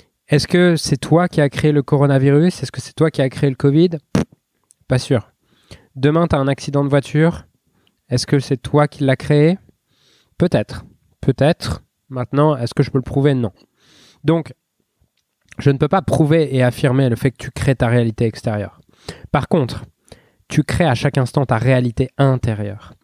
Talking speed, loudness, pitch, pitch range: 180 wpm, -17 LUFS, 140 Hz, 125-150 Hz